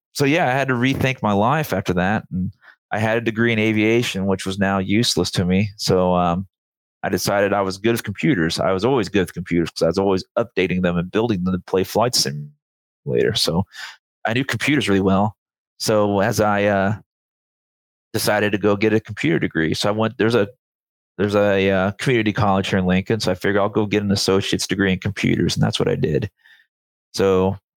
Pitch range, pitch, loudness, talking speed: 95-110 Hz, 100 Hz, -19 LUFS, 210 wpm